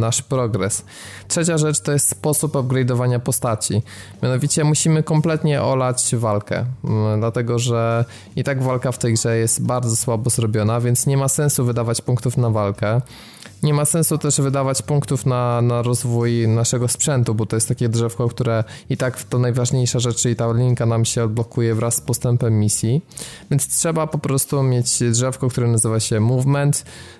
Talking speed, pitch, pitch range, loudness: 170 wpm, 125 Hz, 115-135 Hz, -19 LUFS